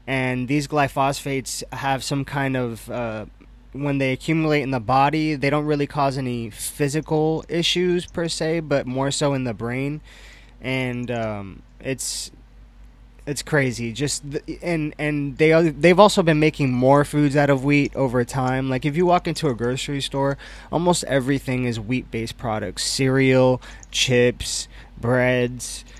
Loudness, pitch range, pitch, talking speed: -21 LUFS, 125-150 Hz, 135 Hz, 155 wpm